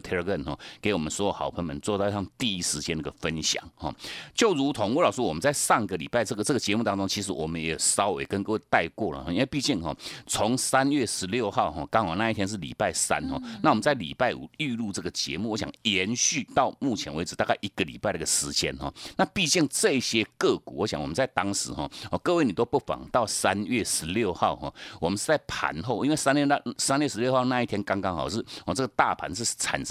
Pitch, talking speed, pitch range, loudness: 105 Hz, 355 characters per minute, 90-125 Hz, -27 LUFS